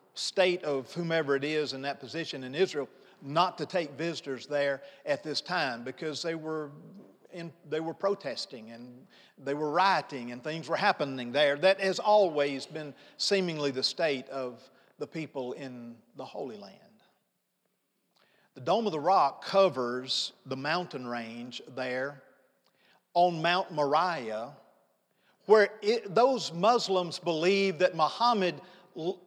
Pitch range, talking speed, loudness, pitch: 140-185 Hz, 140 wpm, -29 LUFS, 155 Hz